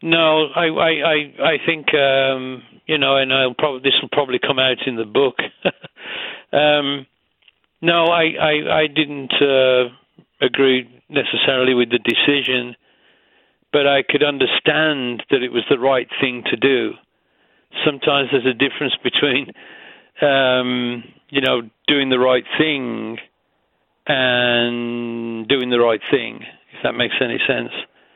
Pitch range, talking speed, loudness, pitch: 125-150 Hz, 140 wpm, -17 LUFS, 135 Hz